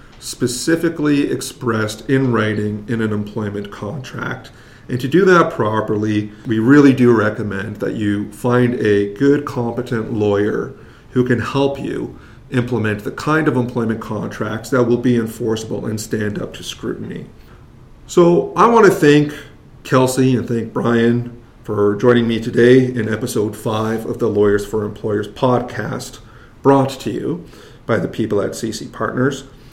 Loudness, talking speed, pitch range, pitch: -17 LUFS, 150 wpm, 110-130 Hz, 120 Hz